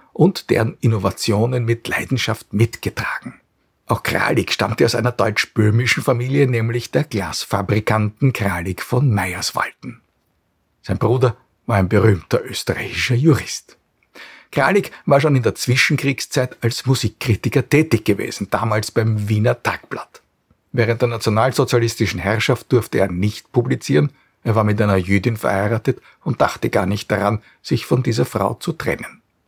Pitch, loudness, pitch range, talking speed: 115 Hz, -19 LUFS, 105-125 Hz, 130 wpm